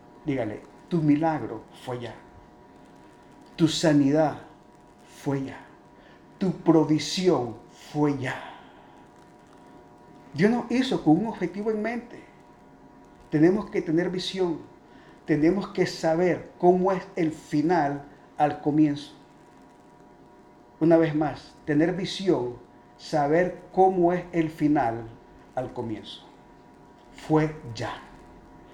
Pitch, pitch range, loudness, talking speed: 155 Hz, 135-180 Hz, -25 LUFS, 100 wpm